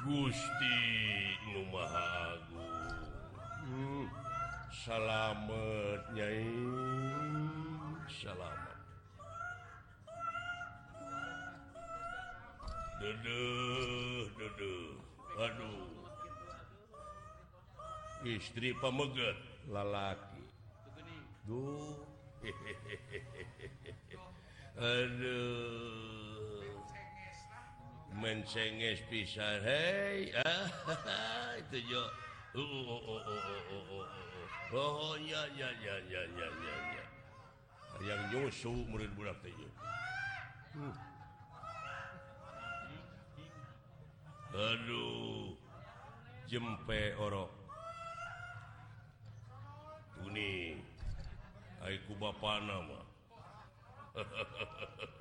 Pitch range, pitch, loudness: 105-135 Hz, 115 Hz, -41 LUFS